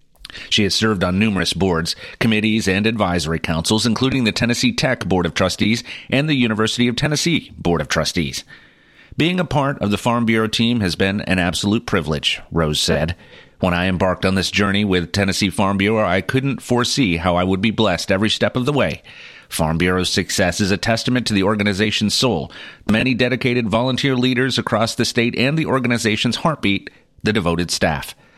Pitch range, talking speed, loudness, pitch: 95-120 Hz, 185 wpm, -18 LUFS, 110 Hz